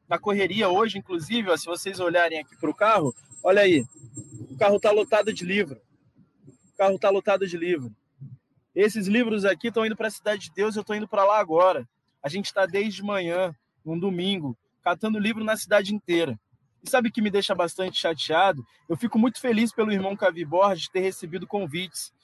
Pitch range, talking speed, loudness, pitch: 165-210 Hz, 195 wpm, -24 LUFS, 195 Hz